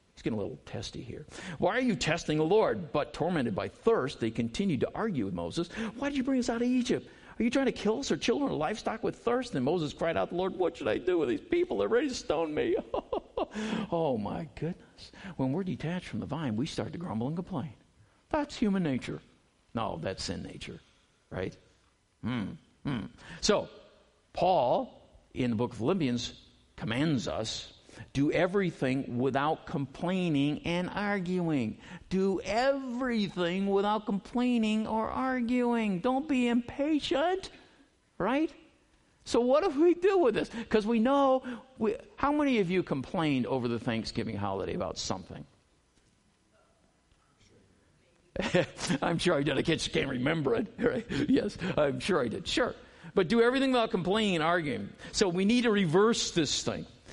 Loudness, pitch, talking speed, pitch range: -30 LUFS, 205 Hz, 170 wpm, 160-245 Hz